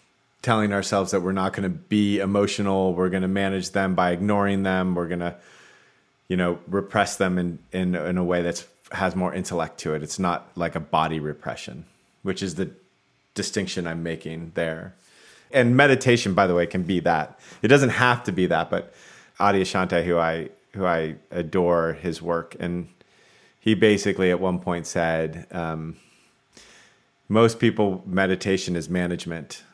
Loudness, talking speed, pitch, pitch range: -23 LUFS, 170 wpm, 90 Hz, 85-100 Hz